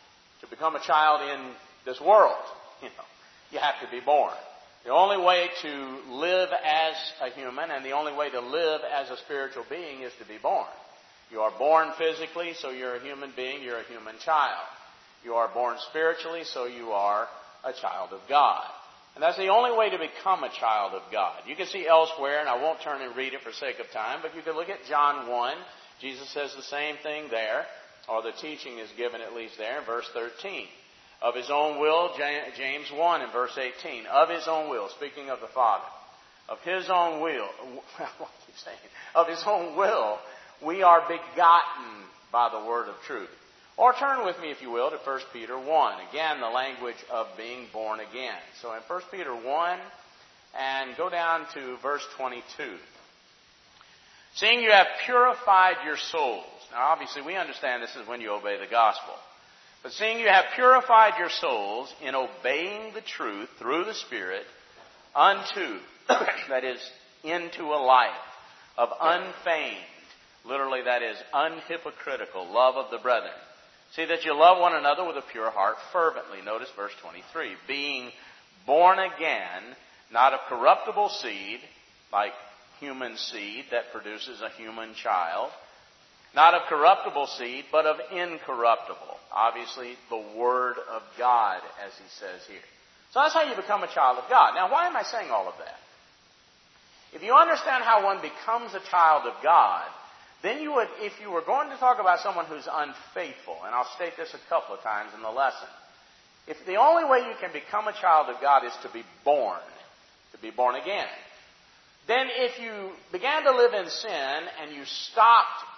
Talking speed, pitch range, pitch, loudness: 180 wpm, 125-180 Hz, 155 Hz, -26 LUFS